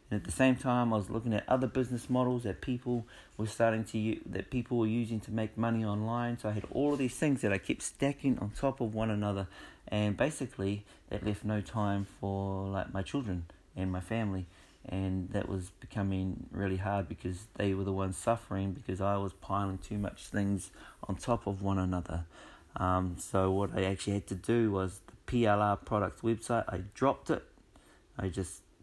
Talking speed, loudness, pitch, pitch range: 200 wpm, -34 LUFS, 105 Hz, 95-115 Hz